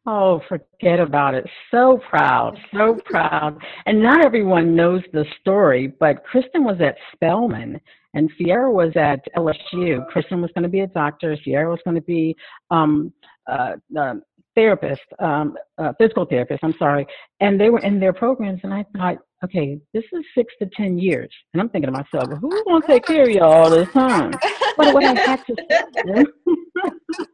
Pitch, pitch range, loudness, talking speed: 185 Hz, 160-255 Hz, -18 LUFS, 185 wpm